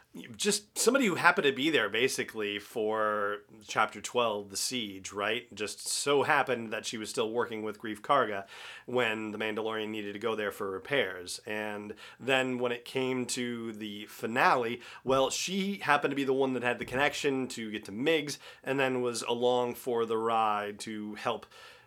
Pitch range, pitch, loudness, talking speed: 105-135 Hz, 120 Hz, -31 LUFS, 180 wpm